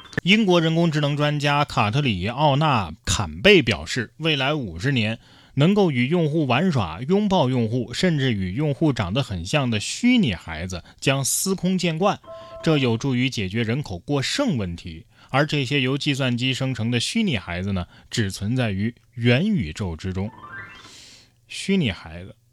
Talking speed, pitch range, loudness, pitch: 245 characters per minute, 105-150 Hz, -22 LUFS, 125 Hz